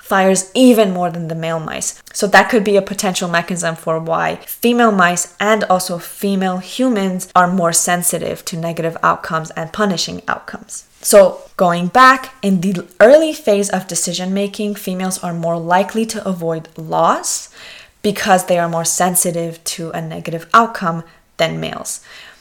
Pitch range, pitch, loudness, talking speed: 170-205 Hz, 185 Hz, -15 LUFS, 155 wpm